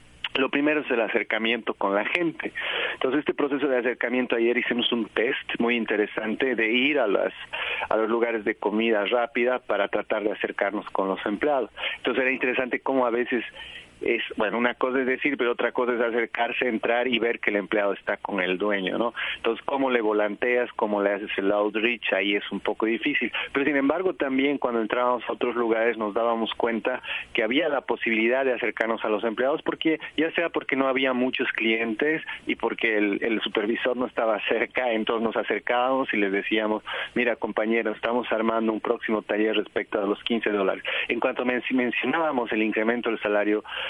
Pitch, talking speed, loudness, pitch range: 115 Hz, 190 wpm, -25 LUFS, 110-125 Hz